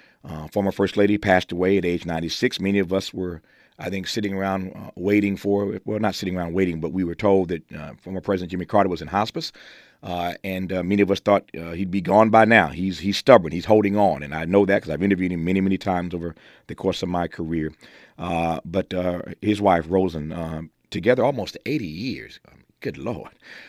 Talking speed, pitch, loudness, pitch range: 225 wpm, 95 Hz, -22 LUFS, 85-100 Hz